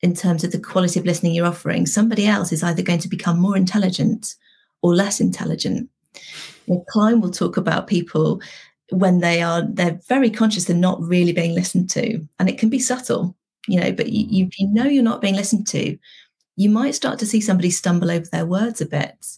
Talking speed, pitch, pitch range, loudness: 205 wpm, 185 Hz, 175-220 Hz, -19 LUFS